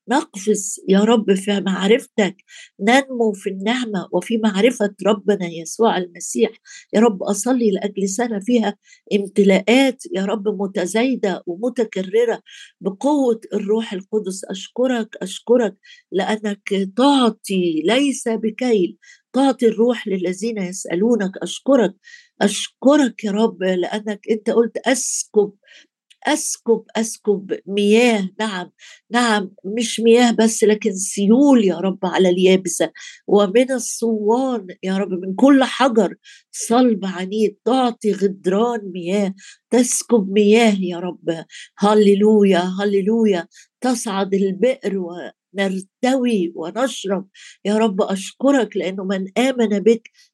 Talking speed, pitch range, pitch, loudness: 105 wpm, 195-240 Hz, 215 Hz, -18 LUFS